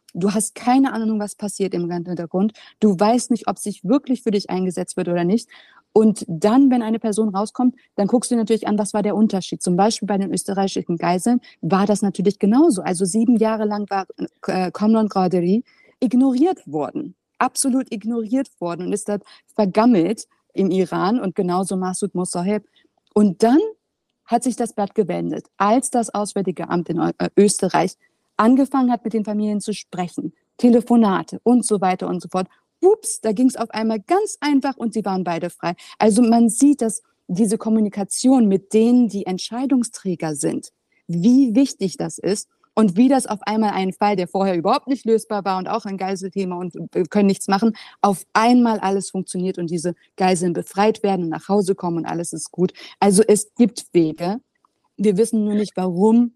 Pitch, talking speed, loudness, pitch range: 210 Hz, 180 wpm, -20 LUFS, 185-235 Hz